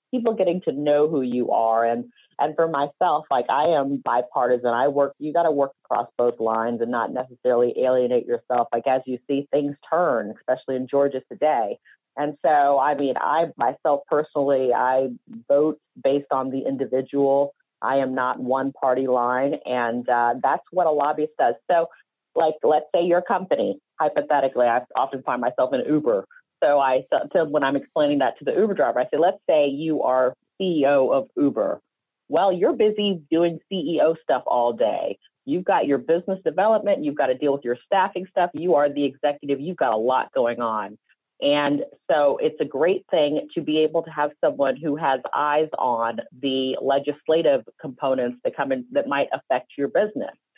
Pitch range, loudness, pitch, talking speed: 130-165 Hz, -22 LUFS, 140 Hz, 185 wpm